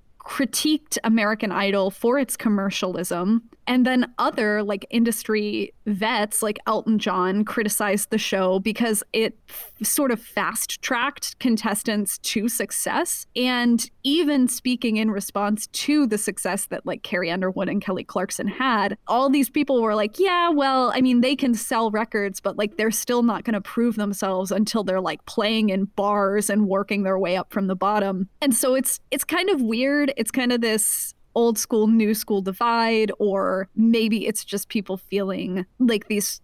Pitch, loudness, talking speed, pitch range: 220 Hz, -22 LUFS, 170 wpm, 200-245 Hz